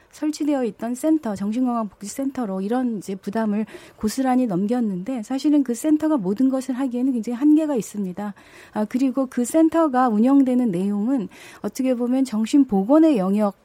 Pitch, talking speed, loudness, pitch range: 245 Hz, 370 characters per minute, -21 LUFS, 210-270 Hz